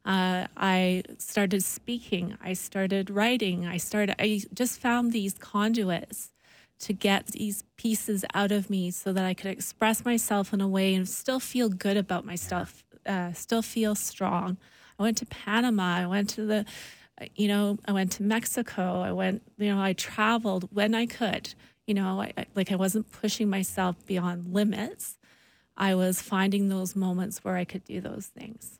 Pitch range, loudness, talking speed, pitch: 190-215 Hz, -28 LUFS, 175 wpm, 200 Hz